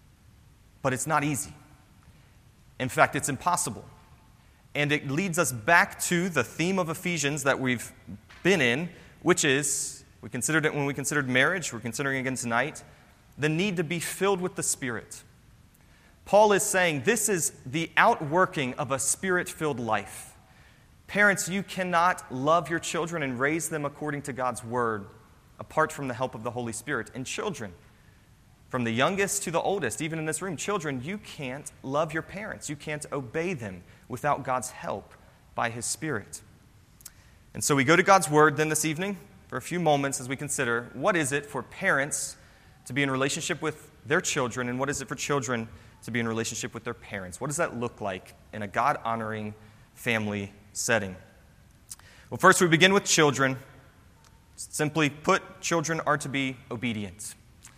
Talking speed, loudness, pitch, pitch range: 175 wpm, -27 LUFS, 140 Hz, 120-165 Hz